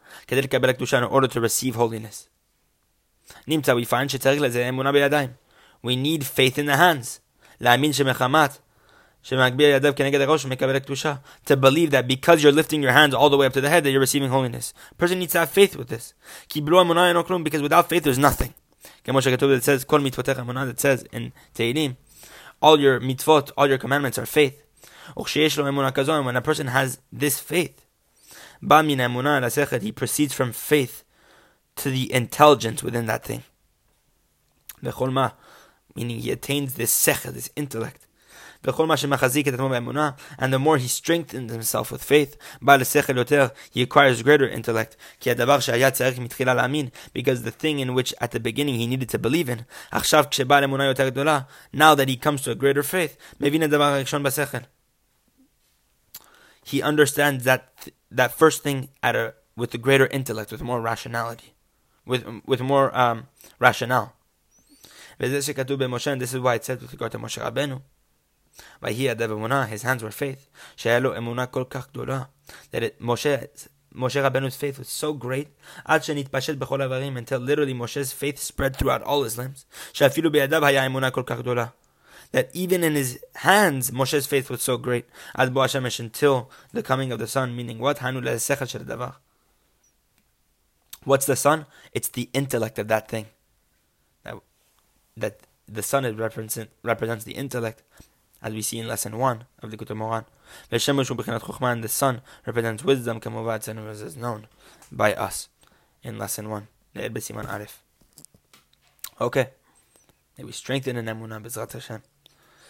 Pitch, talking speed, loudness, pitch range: 135 Hz, 120 wpm, -22 LUFS, 120-145 Hz